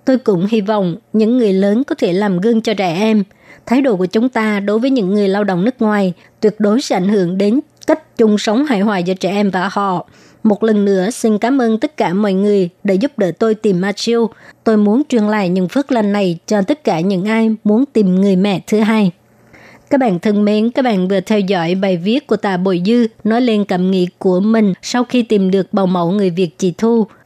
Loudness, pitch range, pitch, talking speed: -14 LUFS, 190-225 Hz, 210 Hz, 240 wpm